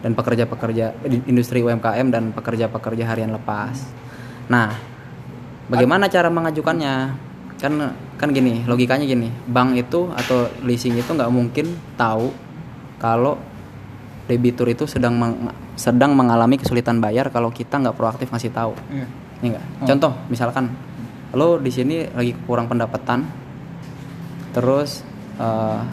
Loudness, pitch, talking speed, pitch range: -20 LUFS, 125 Hz, 120 wpm, 115-135 Hz